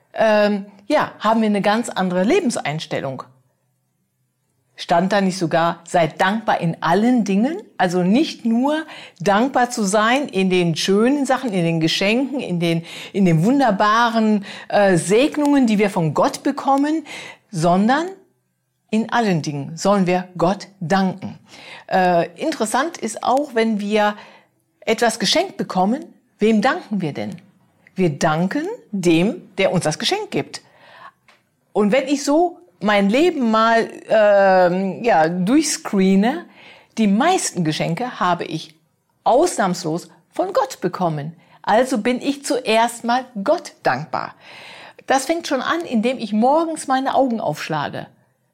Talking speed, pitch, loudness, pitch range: 130 wpm, 210 Hz, -19 LUFS, 180-255 Hz